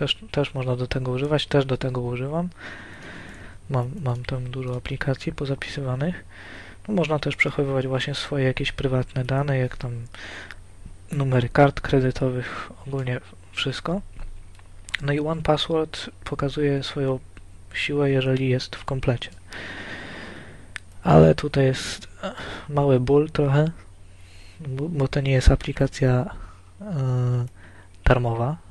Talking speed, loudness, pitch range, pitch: 120 wpm, -24 LUFS, 95-140 Hz, 130 Hz